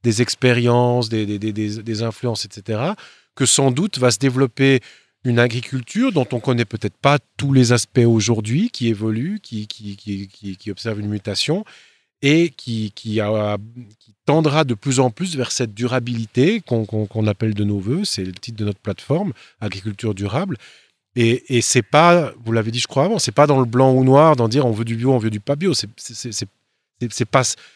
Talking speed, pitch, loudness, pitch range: 210 wpm, 120 Hz, -19 LUFS, 110-135 Hz